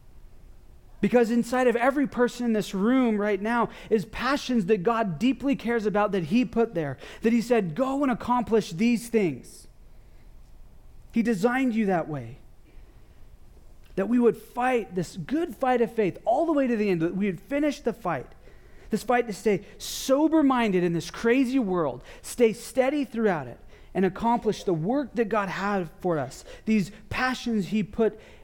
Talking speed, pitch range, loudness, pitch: 170 wpm, 190-245 Hz, -26 LUFS, 225 Hz